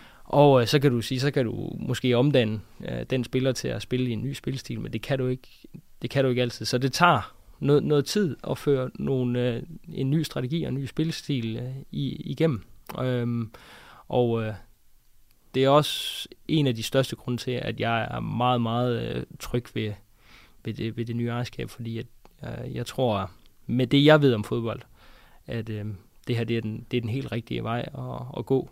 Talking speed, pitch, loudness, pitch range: 215 wpm, 125 Hz, -26 LUFS, 115-135 Hz